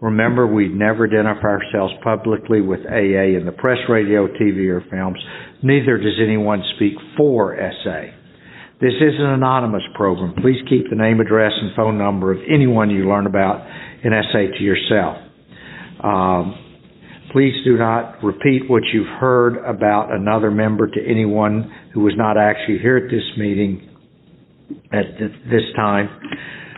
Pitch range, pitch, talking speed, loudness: 100-120 Hz, 110 Hz, 150 wpm, -17 LUFS